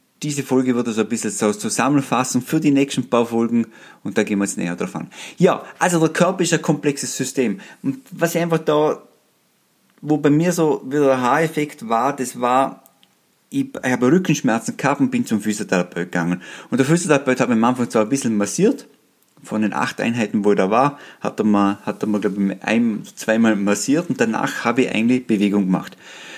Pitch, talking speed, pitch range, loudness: 125 Hz, 200 wpm, 110-150 Hz, -19 LUFS